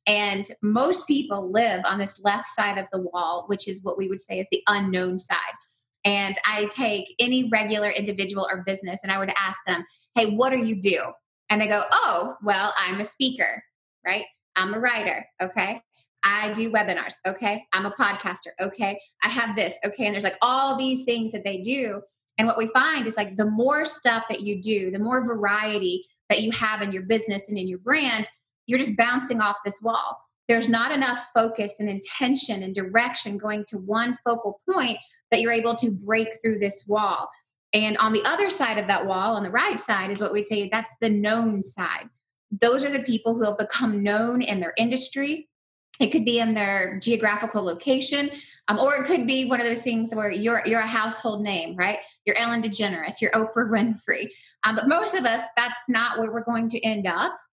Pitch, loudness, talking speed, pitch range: 220 Hz, -24 LUFS, 205 wpm, 200-235 Hz